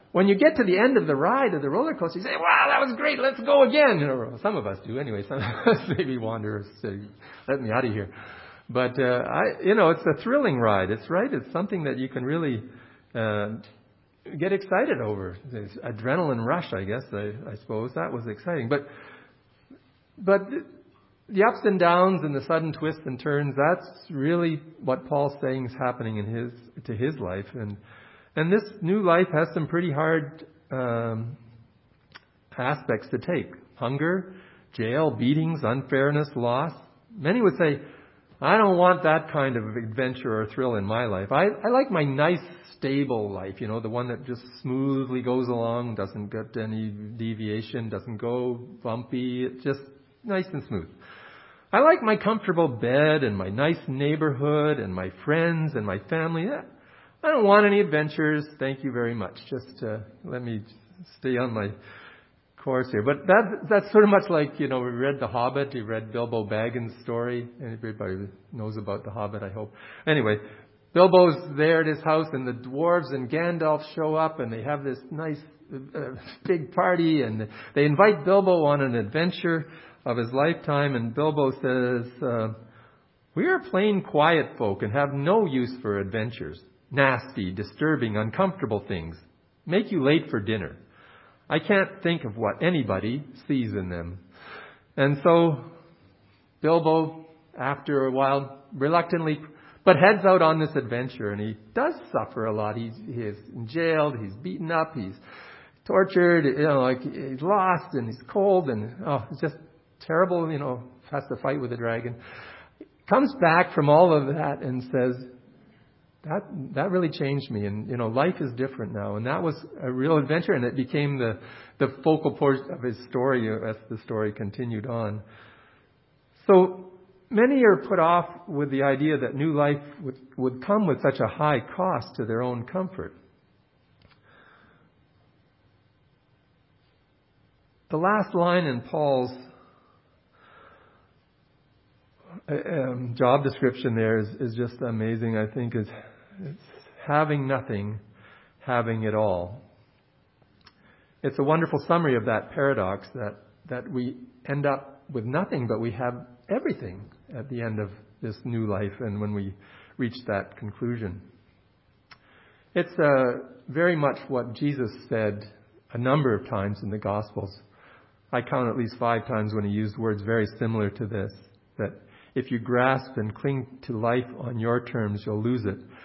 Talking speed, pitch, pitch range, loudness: 165 wpm, 130 Hz, 110-155 Hz, -25 LUFS